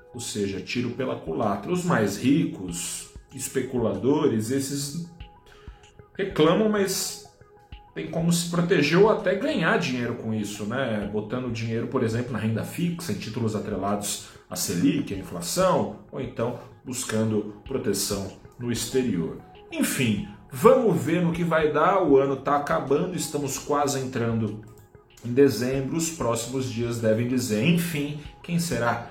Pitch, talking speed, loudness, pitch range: 130 Hz, 140 wpm, -25 LUFS, 110-155 Hz